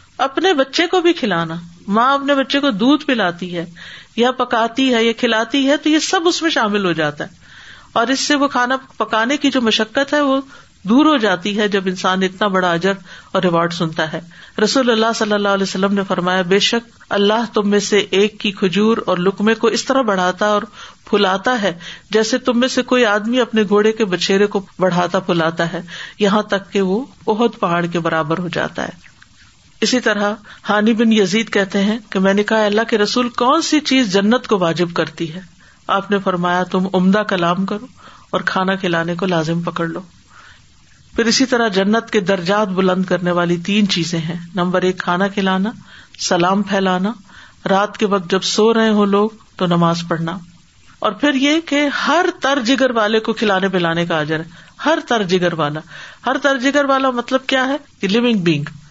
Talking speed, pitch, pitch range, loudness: 200 wpm, 205 Hz, 185-240 Hz, -16 LUFS